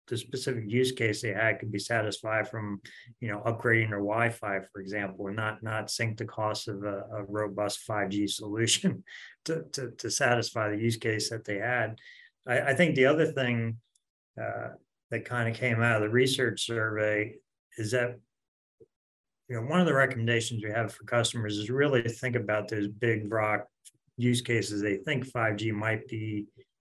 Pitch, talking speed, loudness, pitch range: 115 Hz, 190 wpm, -29 LUFS, 105-120 Hz